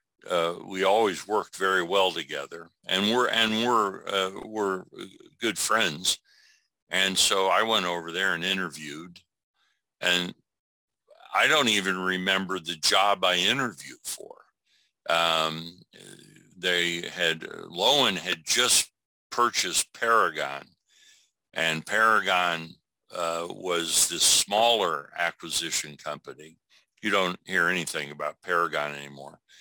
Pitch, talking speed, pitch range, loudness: 90 Hz, 115 wpm, 80-95 Hz, -25 LUFS